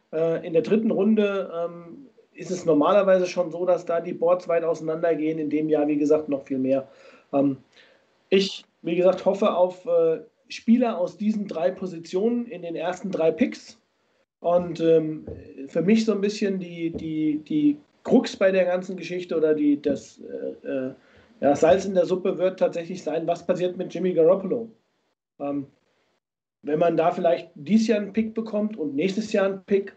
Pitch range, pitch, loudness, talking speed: 165-205 Hz, 180 Hz, -24 LUFS, 180 wpm